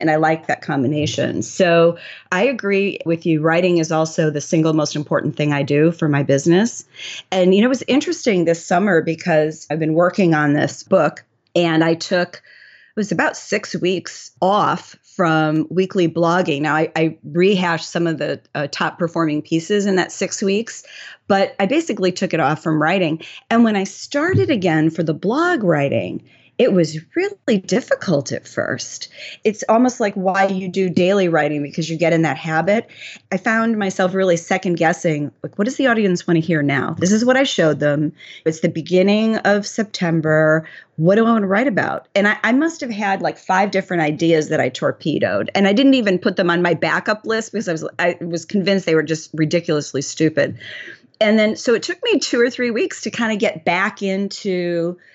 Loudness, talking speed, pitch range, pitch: -18 LUFS, 200 wpm, 160-205 Hz, 180 Hz